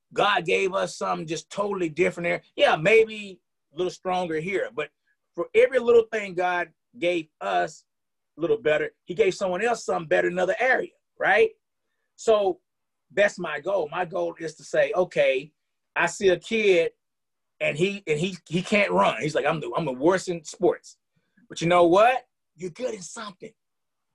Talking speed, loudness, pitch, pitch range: 180 wpm, -24 LUFS, 185 Hz, 170-225 Hz